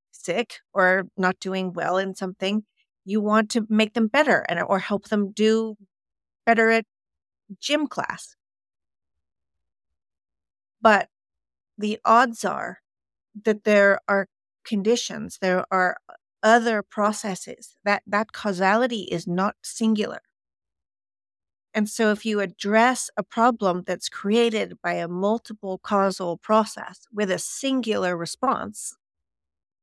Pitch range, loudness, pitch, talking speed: 175-220 Hz, -23 LUFS, 200 Hz, 115 wpm